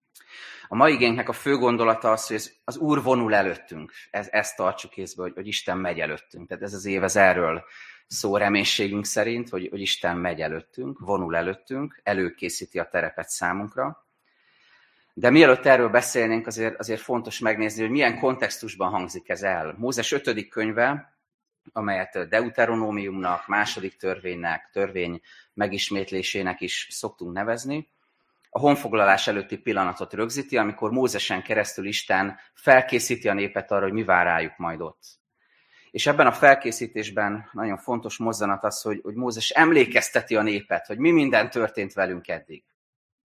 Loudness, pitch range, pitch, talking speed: -23 LUFS, 100-120 Hz, 105 Hz, 145 wpm